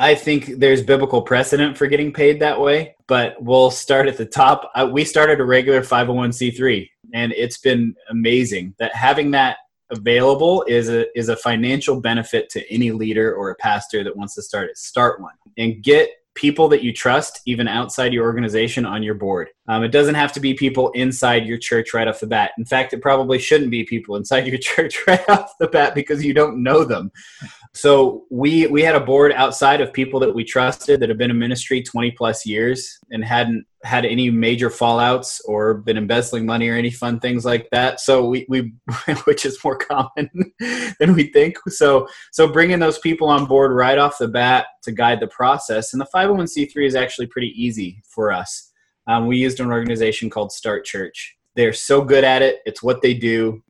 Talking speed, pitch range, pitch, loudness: 200 wpm, 115-145 Hz, 125 Hz, -17 LUFS